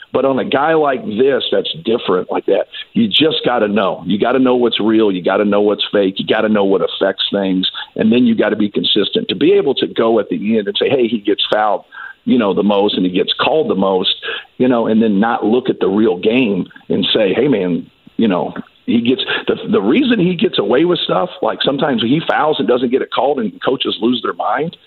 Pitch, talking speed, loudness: 130 Hz, 240 wpm, -15 LUFS